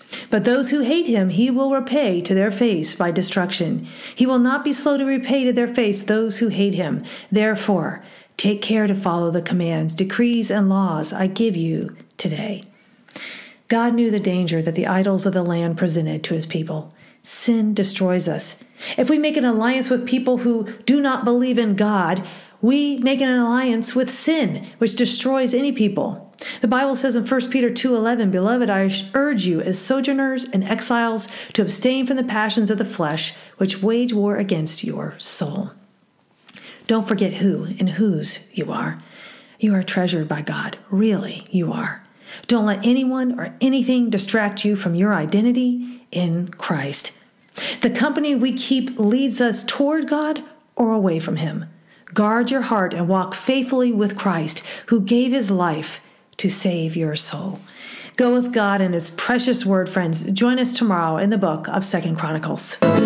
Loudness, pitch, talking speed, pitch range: -20 LUFS, 215 Hz, 175 wpm, 190-250 Hz